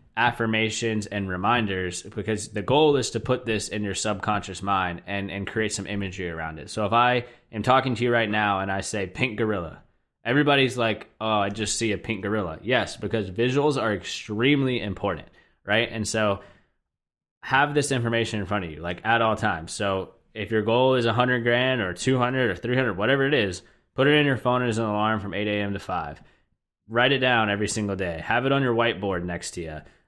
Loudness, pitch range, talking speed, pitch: -24 LUFS, 100-120 Hz, 215 wpm, 110 Hz